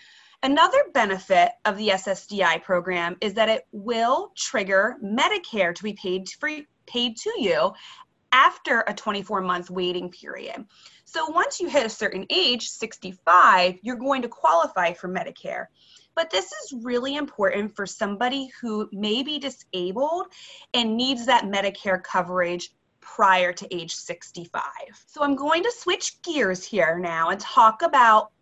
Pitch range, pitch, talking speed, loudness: 185-275 Hz, 215 Hz, 150 wpm, -23 LUFS